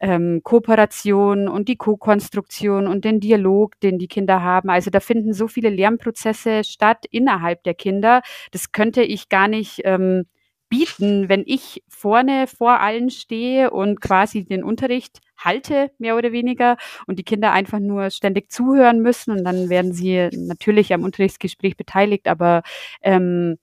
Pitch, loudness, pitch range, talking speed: 210 Hz, -18 LUFS, 190-235 Hz, 155 wpm